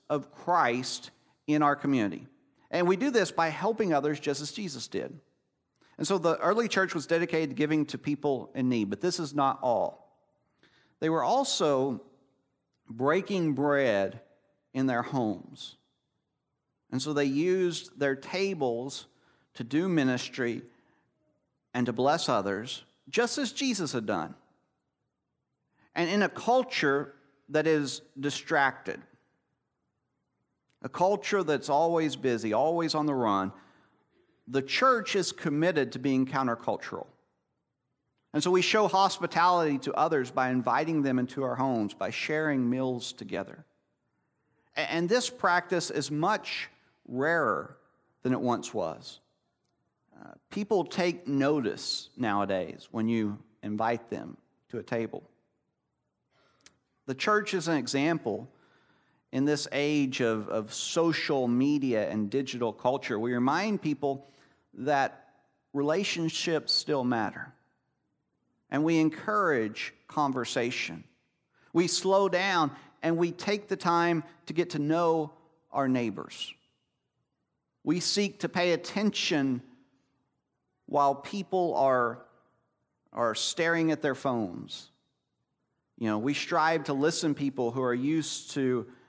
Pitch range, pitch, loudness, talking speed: 130-170 Hz, 145 Hz, -29 LUFS, 125 wpm